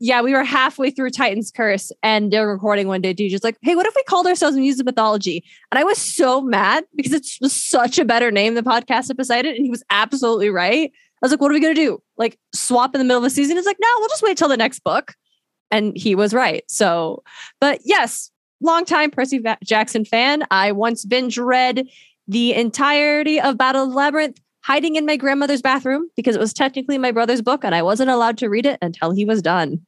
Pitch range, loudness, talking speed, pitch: 220-285 Hz, -18 LUFS, 240 wpm, 255 Hz